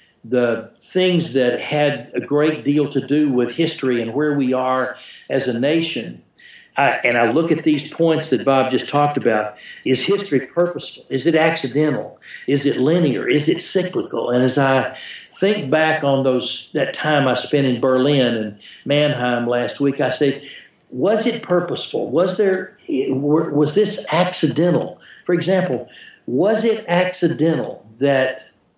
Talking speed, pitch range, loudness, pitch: 155 wpm, 130-165 Hz, -18 LUFS, 145 Hz